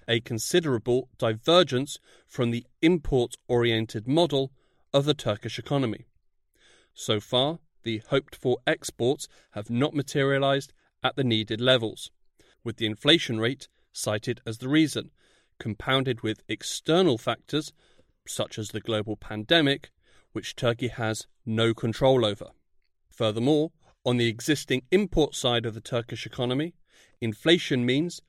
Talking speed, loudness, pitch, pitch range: 125 wpm, -26 LUFS, 125 Hz, 115-140 Hz